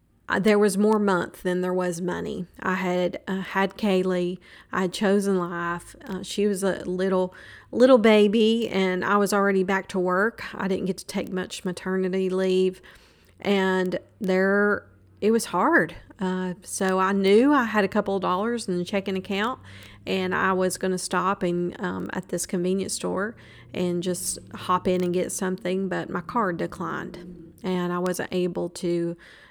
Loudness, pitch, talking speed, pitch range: -24 LUFS, 185 Hz, 175 wpm, 180-200 Hz